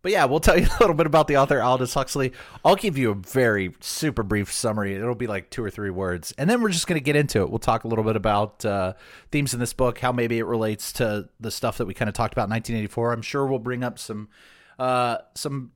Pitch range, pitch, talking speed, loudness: 105-130 Hz, 120 Hz, 270 wpm, -23 LUFS